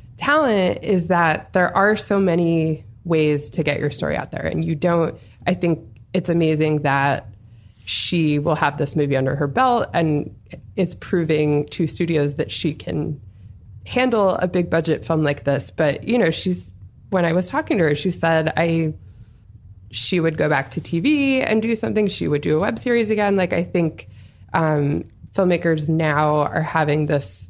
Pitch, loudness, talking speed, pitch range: 160 Hz, -20 LUFS, 180 wpm, 145-180 Hz